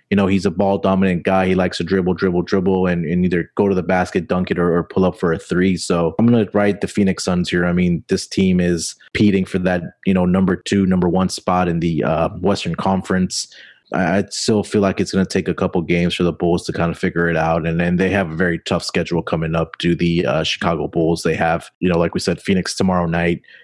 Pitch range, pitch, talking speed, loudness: 85-95 Hz, 90 Hz, 265 wpm, -18 LUFS